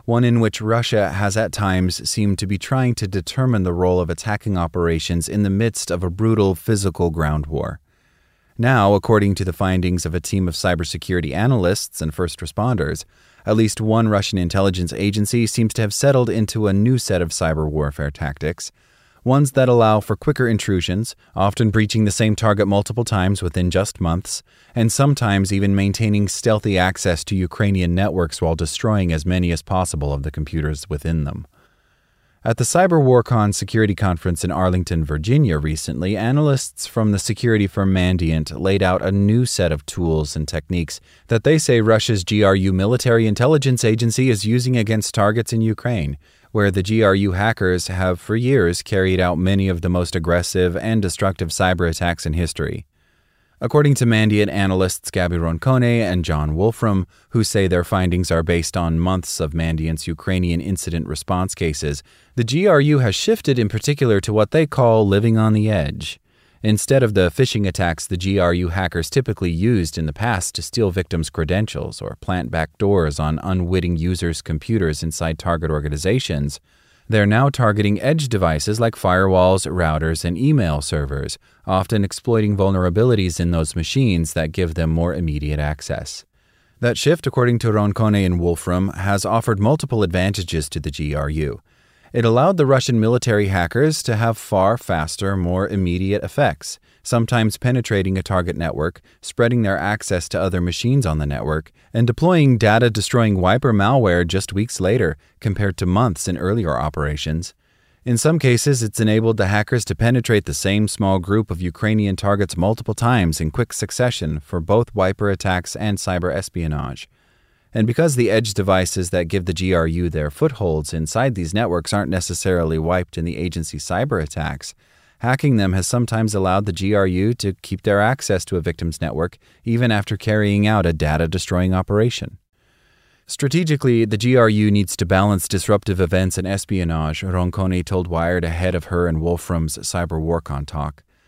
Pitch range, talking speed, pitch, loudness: 85-110 Hz, 165 wpm, 95 Hz, -19 LUFS